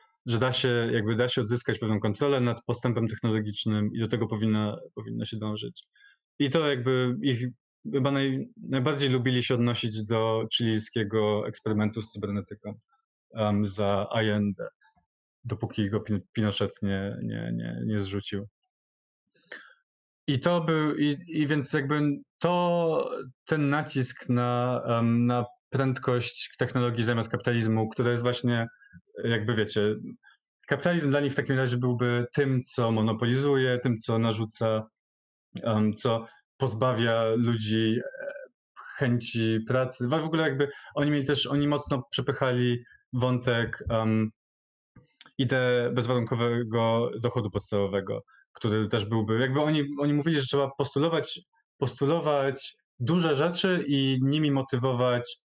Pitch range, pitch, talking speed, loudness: 110-140 Hz, 120 Hz, 125 wpm, -27 LUFS